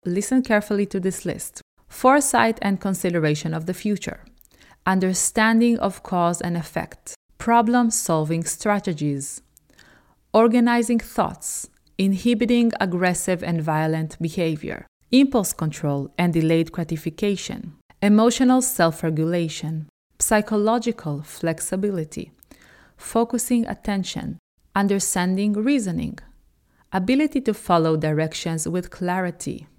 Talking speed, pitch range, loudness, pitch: 95 wpm, 165-225 Hz, -22 LUFS, 190 Hz